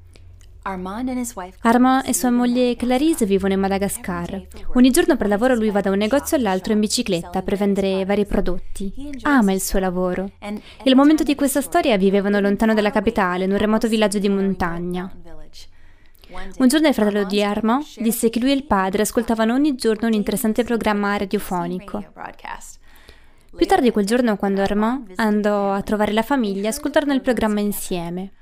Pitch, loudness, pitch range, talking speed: 210 Hz, -19 LUFS, 195-245 Hz, 165 wpm